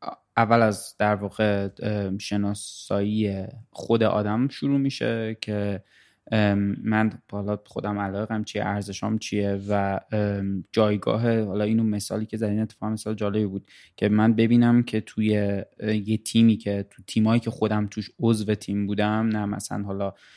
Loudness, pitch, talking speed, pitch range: -25 LUFS, 105 Hz, 140 wpm, 100-110 Hz